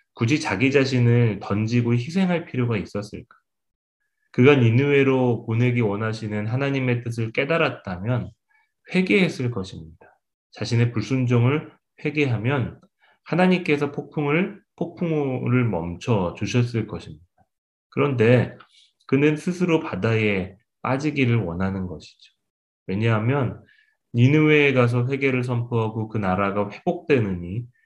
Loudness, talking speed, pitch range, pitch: -22 LUFS, 280 characters per minute, 110-145 Hz, 125 Hz